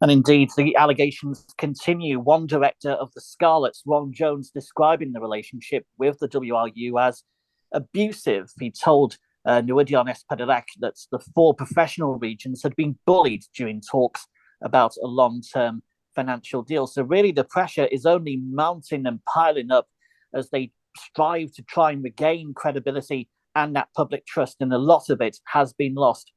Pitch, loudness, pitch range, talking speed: 140 Hz, -22 LUFS, 130-155 Hz, 160 wpm